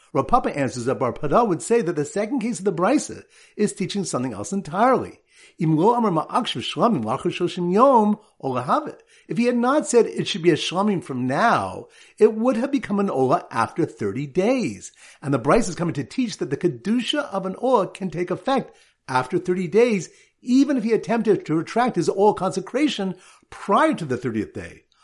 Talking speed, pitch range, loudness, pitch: 175 wpm, 175-245 Hz, -22 LUFS, 200 Hz